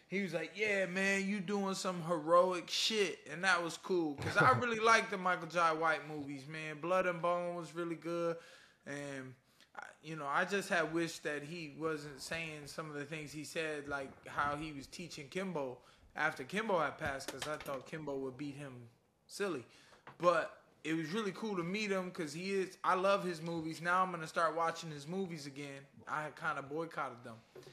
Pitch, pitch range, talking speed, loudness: 165 Hz, 150-185 Hz, 205 wpm, -37 LUFS